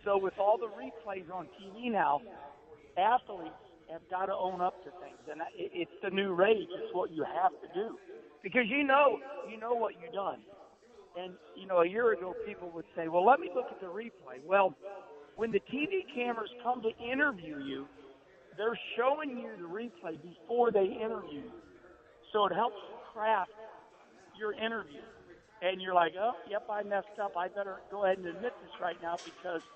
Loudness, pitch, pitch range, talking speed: -33 LUFS, 205 Hz, 185-240 Hz, 190 wpm